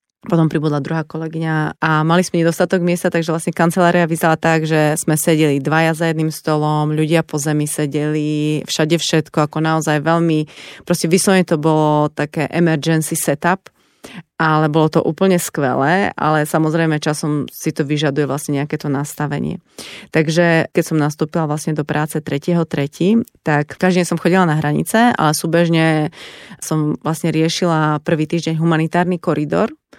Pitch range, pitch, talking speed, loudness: 150-170 Hz, 160 Hz, 150 wpm, -16 LUFS